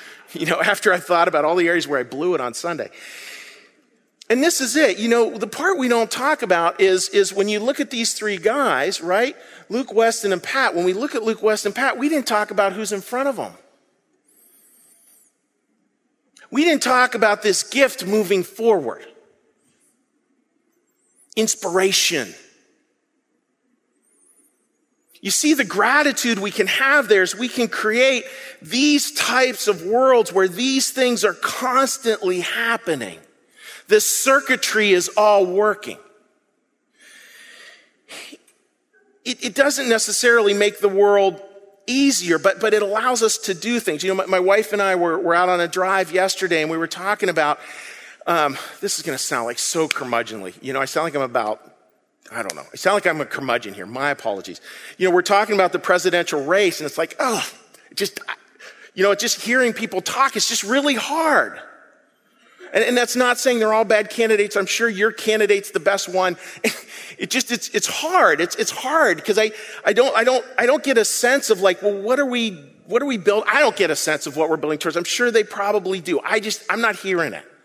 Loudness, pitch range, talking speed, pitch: -19 LUFS, 190-250 Hz, 190 wpm, 215 Hz